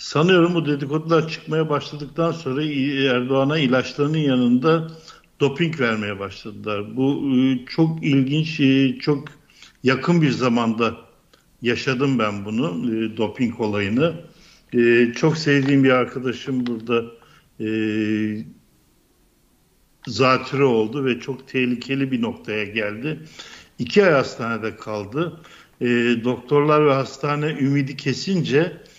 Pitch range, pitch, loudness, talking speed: 120-150 Hz, 135 Hz, -21 LUFS, 95 wpm